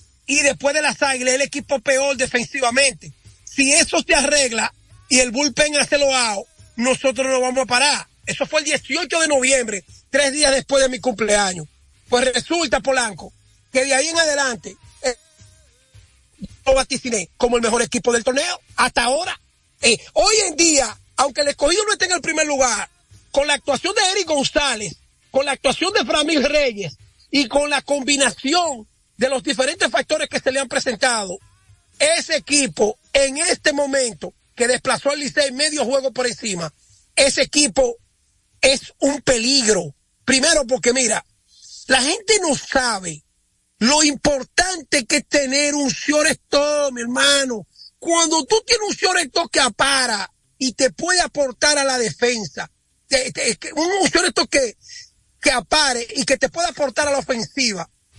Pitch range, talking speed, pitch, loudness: 245-295 Hz, 160 wpm, 275 Hz, -18 LUFS